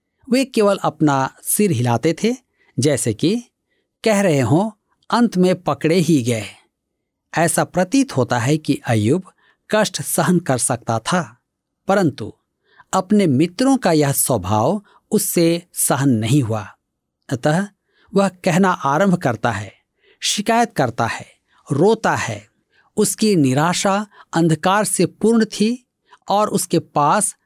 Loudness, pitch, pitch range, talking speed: -18 LUFS, 170 Hz, 140-205 Hz, 125 wpm